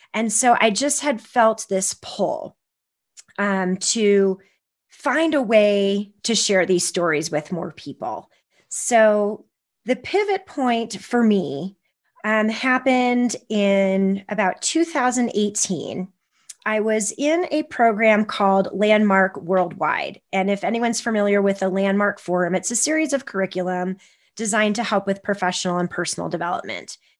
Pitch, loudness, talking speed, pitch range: 205 Hz, -20 LUFS, 130 wpm, 190-235 Hz